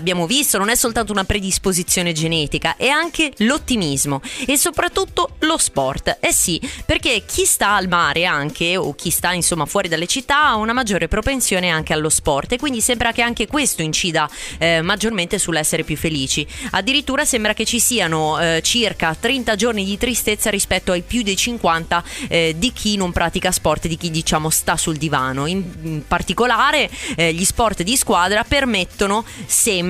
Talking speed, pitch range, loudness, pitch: 175 wpm, 165-240 Hz, -17 LUFS, 195 Hz